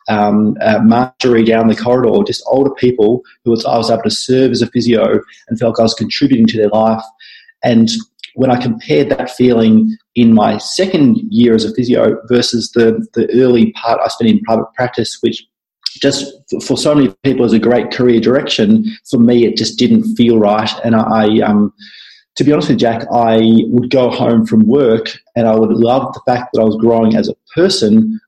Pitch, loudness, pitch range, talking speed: 120 Hz, -12 LUFS, 115-140 Hz, 205 wpm